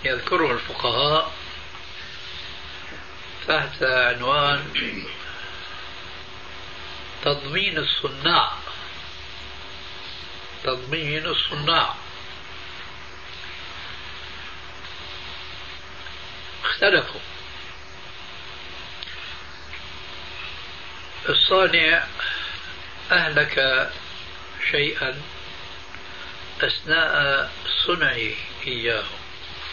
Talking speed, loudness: 30 wpm, -22 LUFS